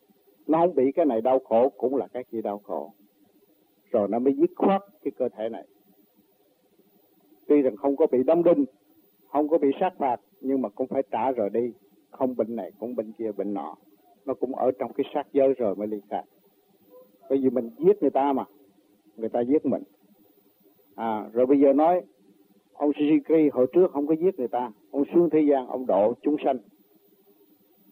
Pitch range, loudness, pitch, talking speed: 105-145 Hz, -25 LUFS, 130 Hz, 200 wpm